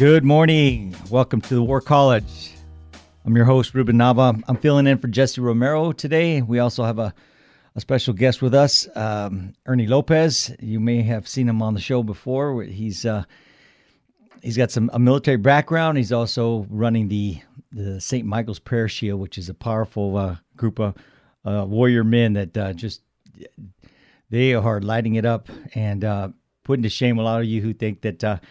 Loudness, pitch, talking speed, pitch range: -20 LUFS, 115 Hz, 185 wpm, 105-130 Hz